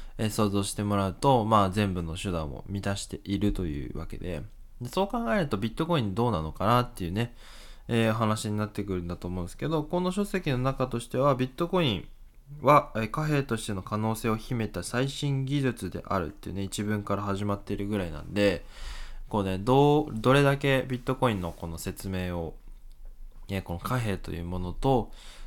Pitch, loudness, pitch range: 110 Hz, -28 LUFS, 95-130 Hz